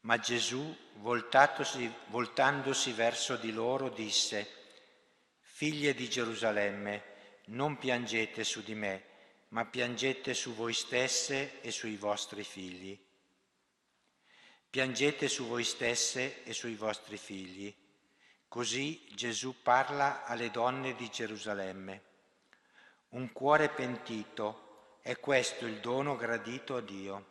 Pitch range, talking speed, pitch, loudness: 105-130 Hz, 110 wpm, 115 Hz, -34 LUFS